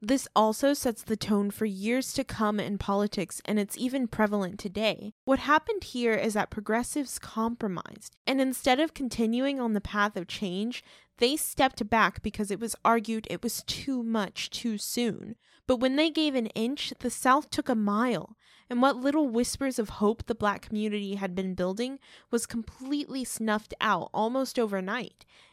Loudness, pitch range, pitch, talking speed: -29 LUFS, 210-260 Hz, 230 Hz, 175 wpm